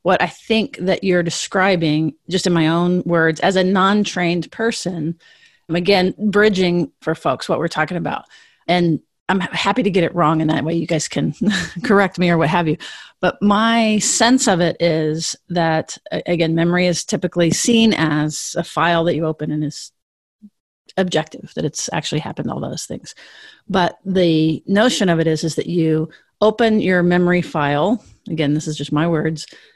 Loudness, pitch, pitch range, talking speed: -18 LUFS, 175 Hz, 160-195 Hz, 180 wpm